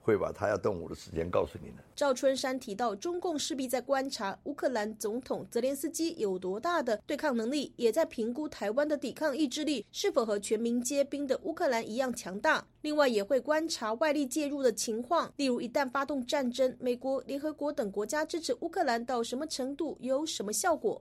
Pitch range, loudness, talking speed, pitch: 240-305 Hz, -32 LUFS, 325 characters per minute, 275 Hz